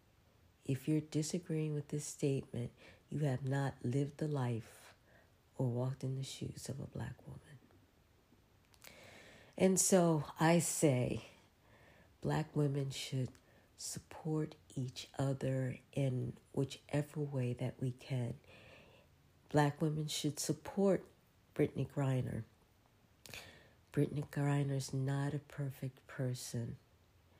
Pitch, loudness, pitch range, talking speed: 135 Hz, -38 LUFS, 125-150 Hz, 110 wpm